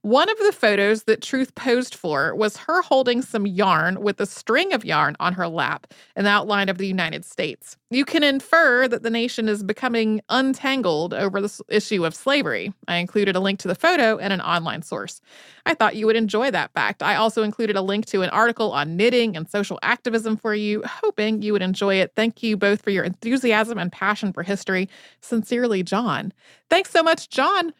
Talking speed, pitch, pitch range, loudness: 205 wpm, 215 Hz, 200-245 Hz, -21 LUFS